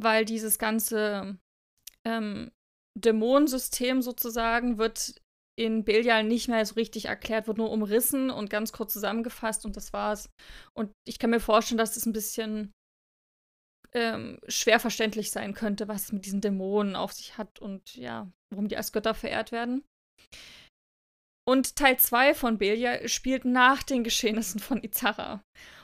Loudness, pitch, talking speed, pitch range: -27 LUFS, 225 Hz, 155 wpm, 210-235 Hz